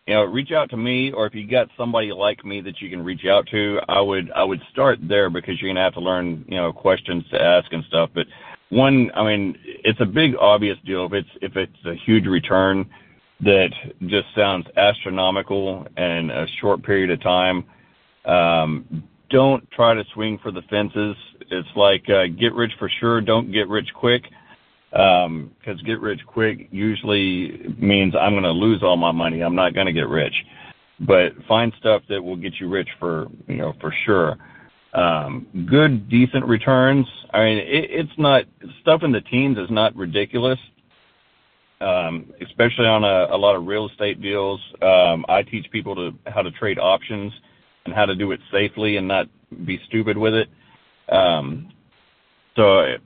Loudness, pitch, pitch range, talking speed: -19 LUFS, 105 Hz, 95-115 Hz, 190 wpm